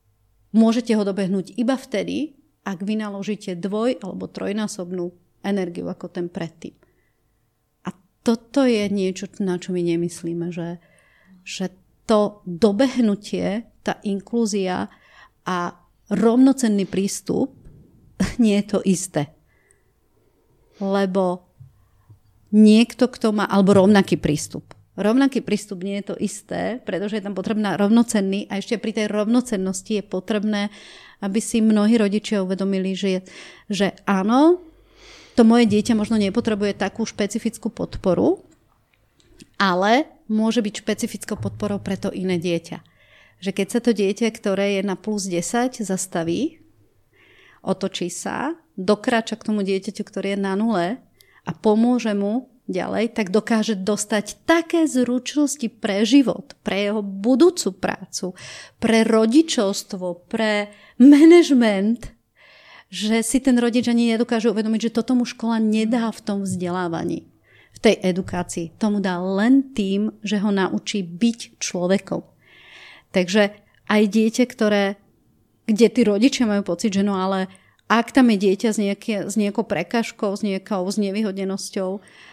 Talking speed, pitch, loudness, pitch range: 130 wpm, 205 Hz, -21 LUFS, 190-230 Hz